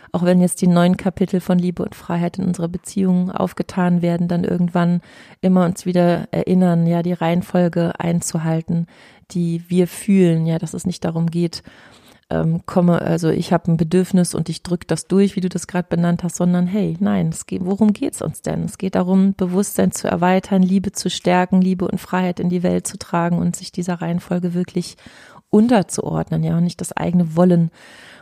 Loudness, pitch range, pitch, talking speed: -19 LUFS, 170-185 Hz, 180 Hz, 190 wpm